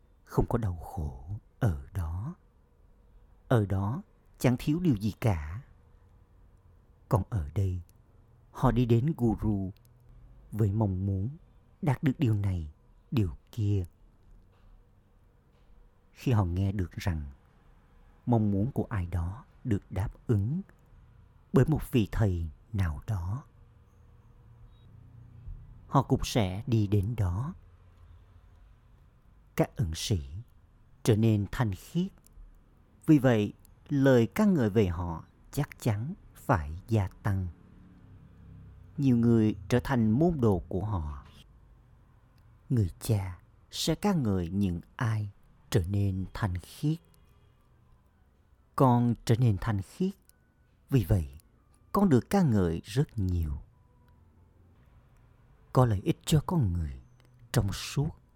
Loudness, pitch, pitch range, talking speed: -30 LUFS, 105 Hz, 95-120 Hz, 115 wpm